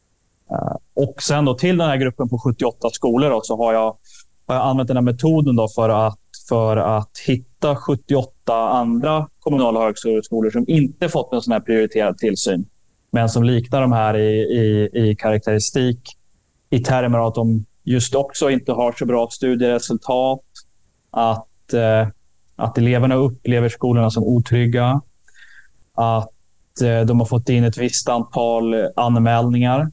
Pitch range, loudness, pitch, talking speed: 115-130 Hz, -18 LUFS, 120 Hz, 150 wpm